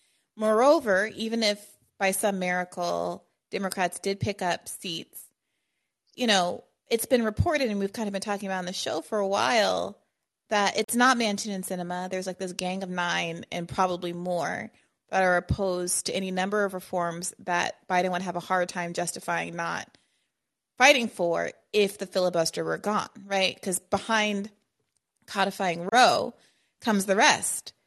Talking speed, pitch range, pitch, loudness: 165 wpm, 180-210 Hz, 195 Hz, -26 LUFS